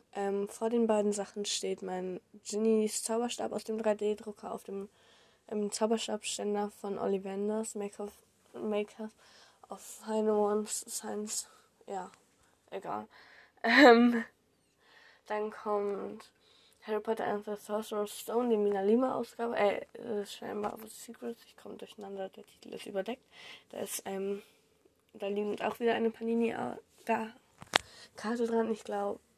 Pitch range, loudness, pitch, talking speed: 205-225 Hz, -33 LUFS, 215 Hz, 135 wpm